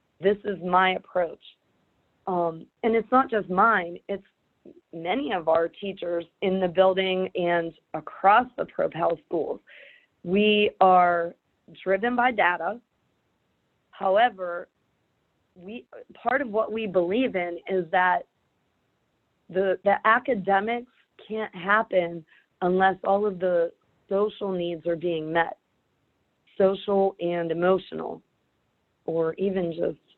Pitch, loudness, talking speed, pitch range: 190 Hz, -25 LUFS, 115 wpm, 175-210 Hz